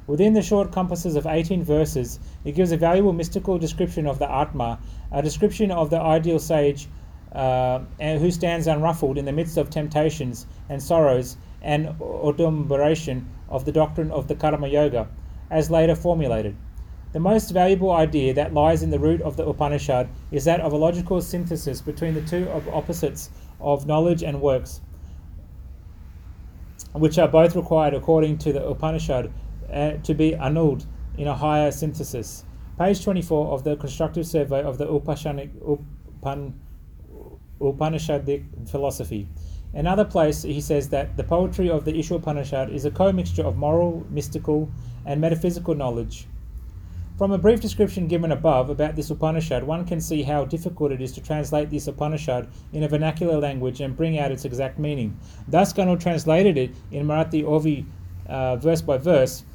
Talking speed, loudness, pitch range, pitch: 160 wpm, -23 LUFS, 135-165 Hz, 150 Hz